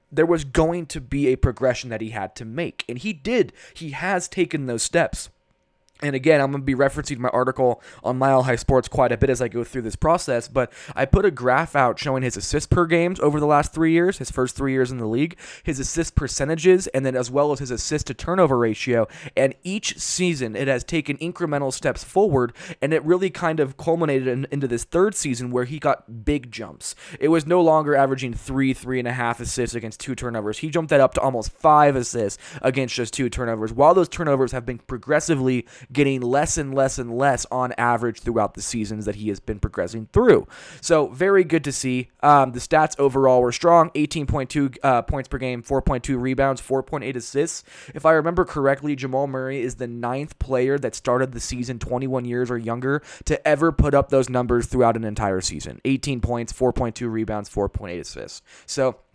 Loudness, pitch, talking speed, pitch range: -22 LUFS, 130 Hz, 205 wpm, 120-150 Hz